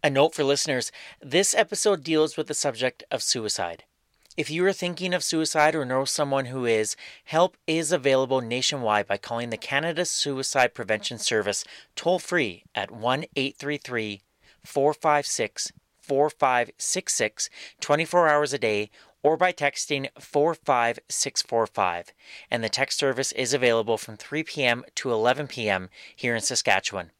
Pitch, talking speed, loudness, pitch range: 140 Hz, 140 wpm, -25 LUFS, 115-155 Hz